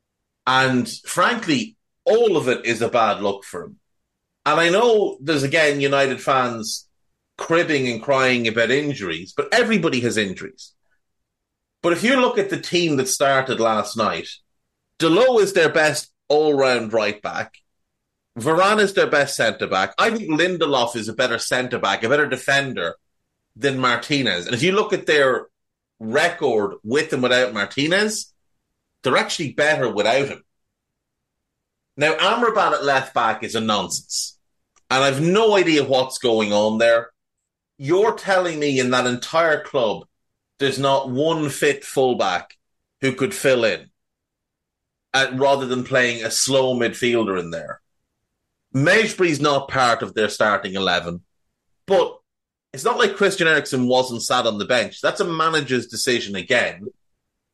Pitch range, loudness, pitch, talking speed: 125-165 Hz, -19 LUFS, 135 Hz, 150 wpm